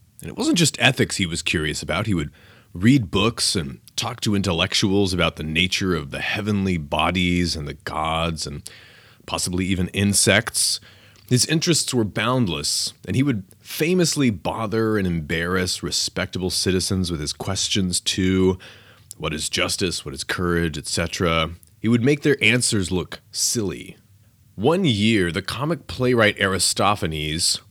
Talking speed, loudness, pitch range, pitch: 145 wpm, -21 LUFS, 90-115 Hz, 100 Hz